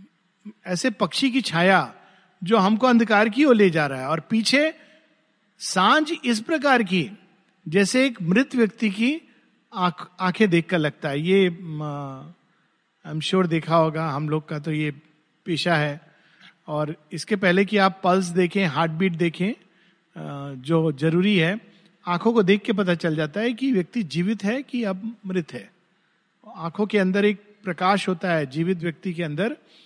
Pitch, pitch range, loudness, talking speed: 185 Hz, 165-210 Hz, -22 LUFS, 155 wpm